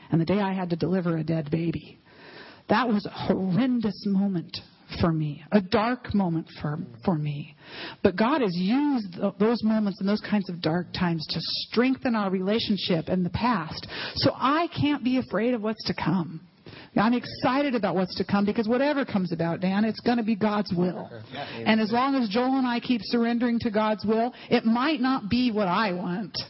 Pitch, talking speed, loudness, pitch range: 205 Hz, 195 wpm, -26 LUFS, 175-235 Hz